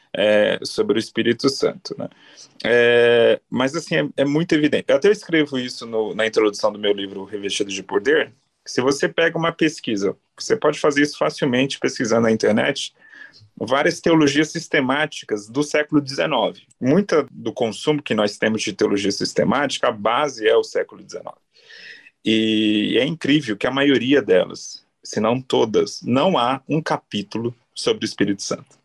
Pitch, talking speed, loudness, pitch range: 135 Hz, 165 wpm, -20 LUFS, 110-160 Hz